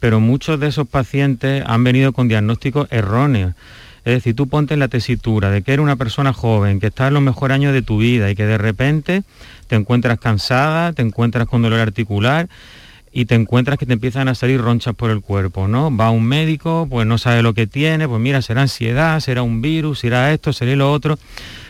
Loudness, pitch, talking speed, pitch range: -16 LUFS, 125 Hz, 215 wpm, 115-140 Hz